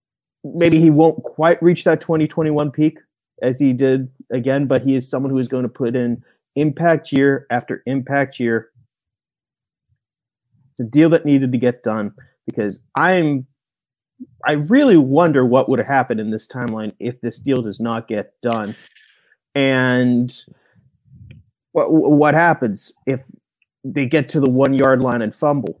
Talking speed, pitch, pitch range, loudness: 160 wpm, 130 Hz, 120-150 Hz, -17 LUFS